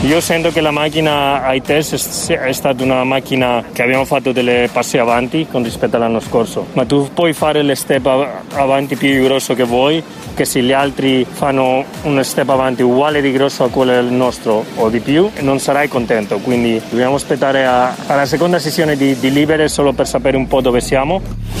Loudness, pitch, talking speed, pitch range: -14 LUFS, 135 Hz, 190 wpm, 125-145 Hz